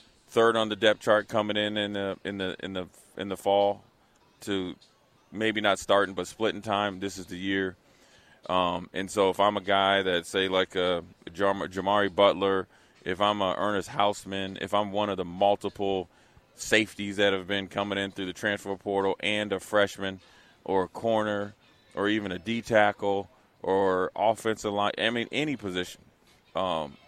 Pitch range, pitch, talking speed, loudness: 95-105 Hz, 100 Hz, 175 wpm, -28 LUFS